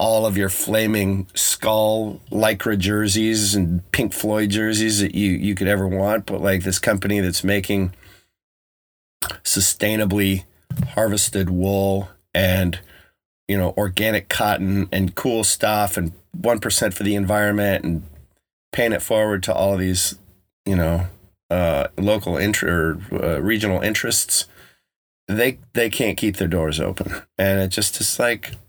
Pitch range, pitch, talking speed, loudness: 95-105 Hz, 100 Hz, 145 wpm, -20 LUFS